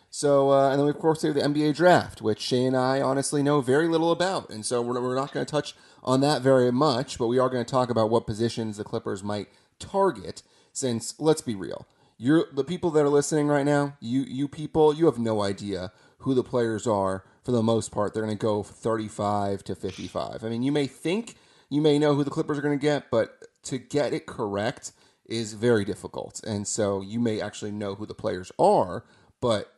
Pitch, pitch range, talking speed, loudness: 130 Hz, 110-145 Hz, 230 wpm, -25 LUFS